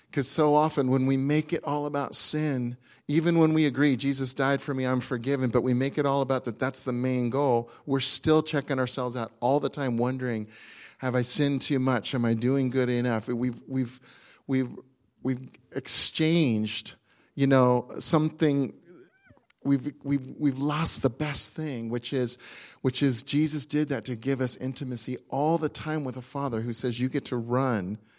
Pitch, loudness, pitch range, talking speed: 130 Hz, -26 LUFS, 125-145 Hz, 185 wpm